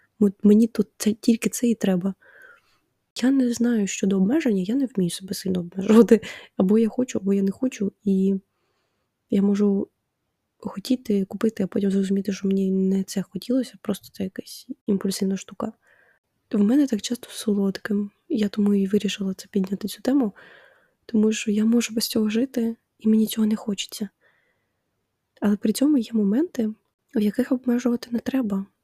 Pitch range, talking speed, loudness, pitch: 195-235 Hz, 165 wpm, -23 LUFS, 210 Hz